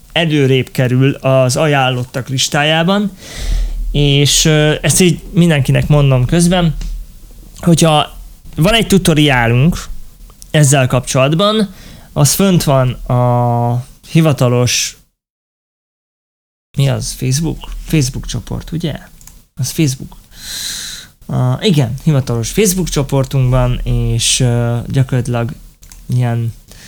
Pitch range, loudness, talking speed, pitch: 125-160 Hz, -13 LUFS, 85 wpm, 135 Hz